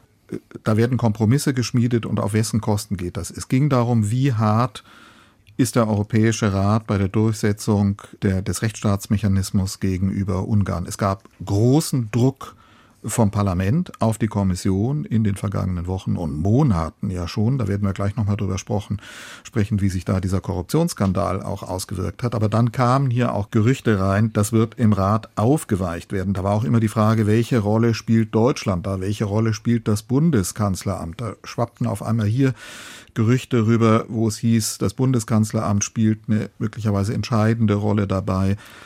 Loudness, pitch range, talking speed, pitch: -21 LUFS, 100-115 Hz, 165 wpm, 110 Hz